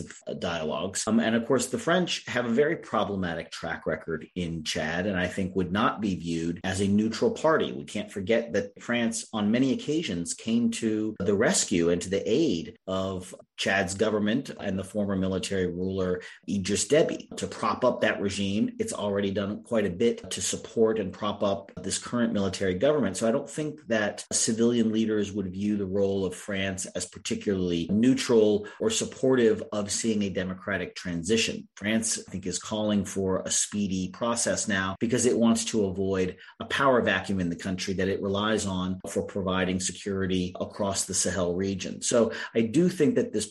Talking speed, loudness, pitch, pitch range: 185 wpm, -27 LUFS, 100 Hz, 95-115 Hz